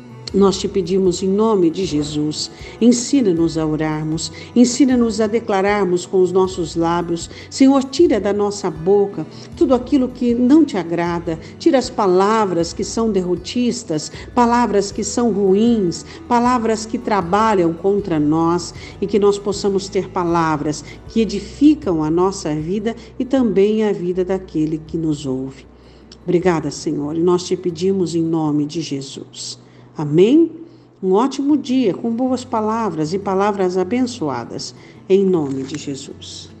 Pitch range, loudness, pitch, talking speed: 165-225 Hz, -18 LUFS, 190 Hz, 140 wpm